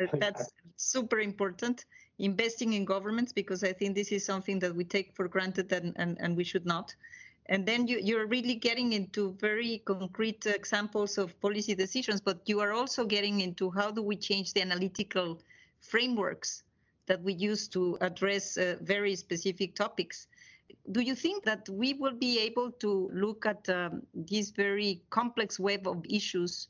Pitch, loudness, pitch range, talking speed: 200 Hz, -32 LUFS, 190-220 Hz, 170 wpm